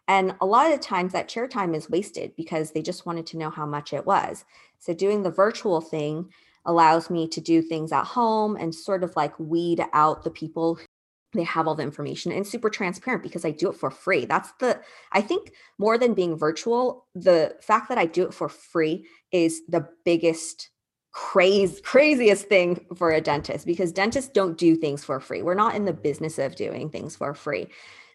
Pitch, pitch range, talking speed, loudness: 170 Hz, 160-200 Hz, 205 wpm, -24 LUFS